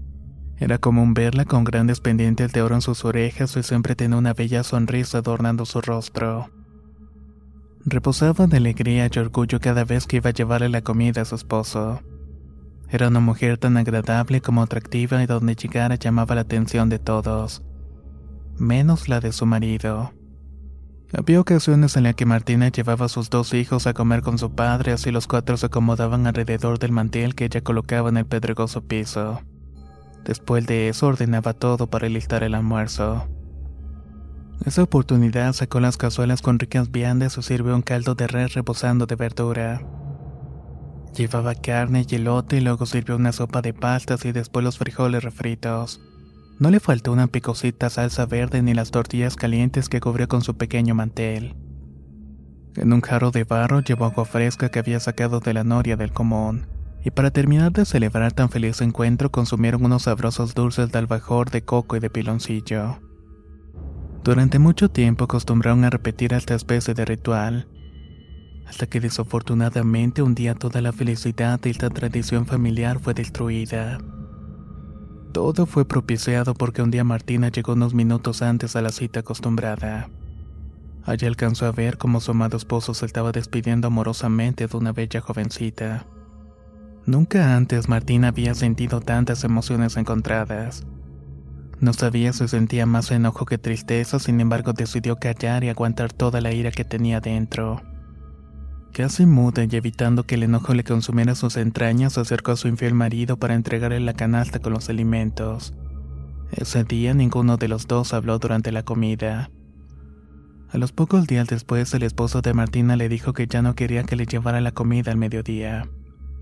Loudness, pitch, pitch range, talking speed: -21 LUFS, 120 Hz, 110-120 Hz, 165 wpm